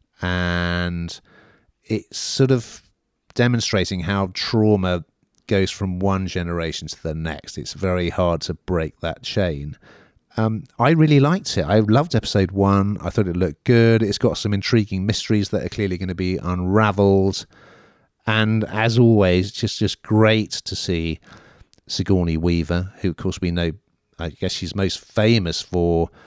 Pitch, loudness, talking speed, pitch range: 95 Hz, -20 LUFS, 160 wpm, 85-110 Hz